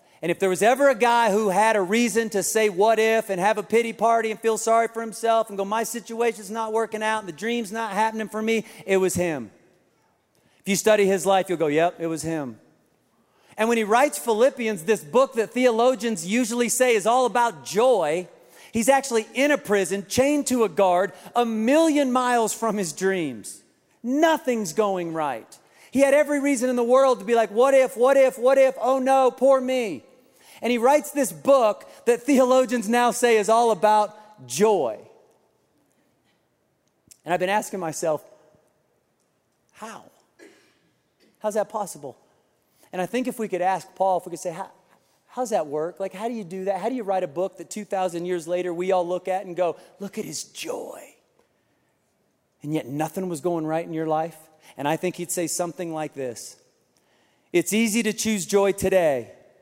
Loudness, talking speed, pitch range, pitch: -22 LUFS, 195 wpm, 185-240 Hz, 220 Hz